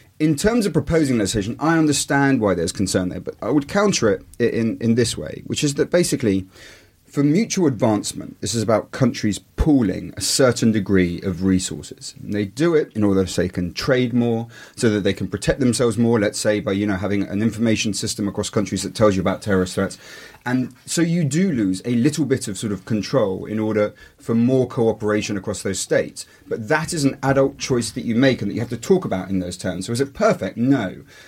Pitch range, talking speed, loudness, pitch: 100-135 Hz, 225 wpm, -20 LUFS, 115 Hz